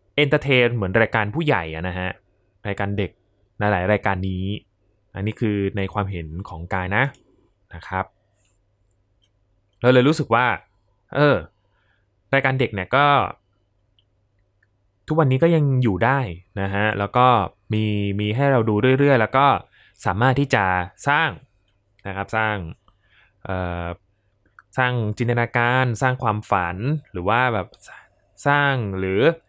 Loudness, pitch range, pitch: -21 LUFS, 100-125 Hz, 105 Hz